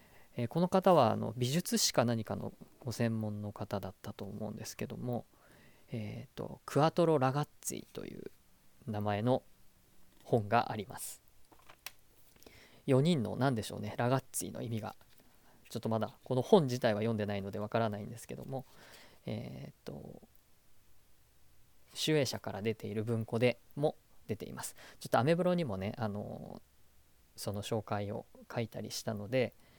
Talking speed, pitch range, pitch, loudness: 280 characters per minute, 105-130 Hz, 115 Hz, -35 LUFS